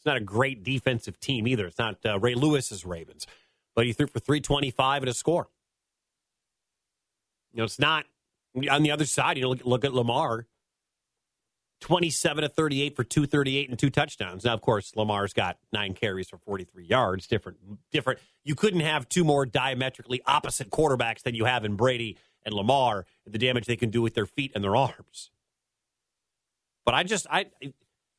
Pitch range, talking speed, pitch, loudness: 110-145 Hz, 180 wpm, 125 Hz, -27 LUFS